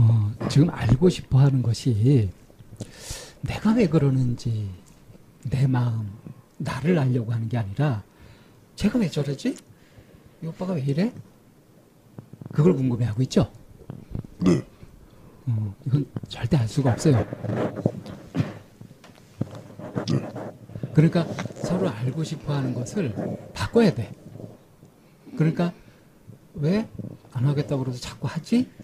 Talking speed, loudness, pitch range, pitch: 210 characters per minute, -24 LUFS, 115-155 Hz, 135 Hz